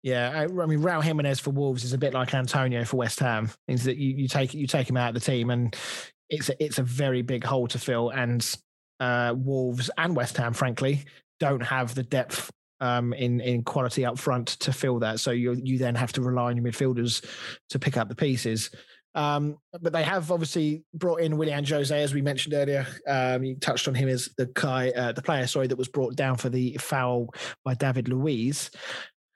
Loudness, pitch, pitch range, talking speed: -27 LUFS, 130 Hz, 125-145 Hz, 220 wpm